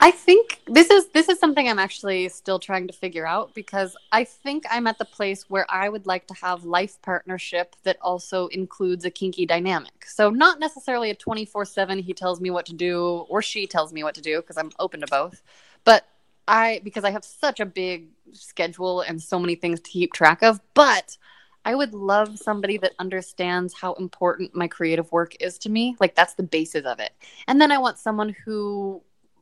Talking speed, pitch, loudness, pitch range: 210 wpm, 190 Hz, -22 LUFS, 175-220 Hz